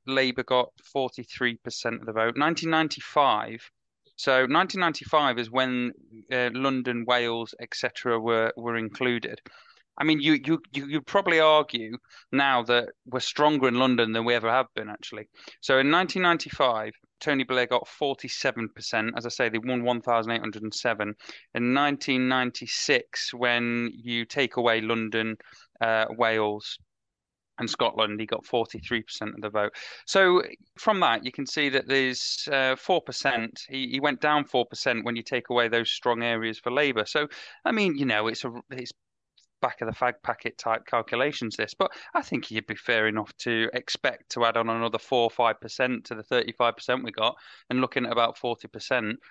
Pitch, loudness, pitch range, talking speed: 120 Hz, -26 LUFS, 115-135 Hz, 195 wpm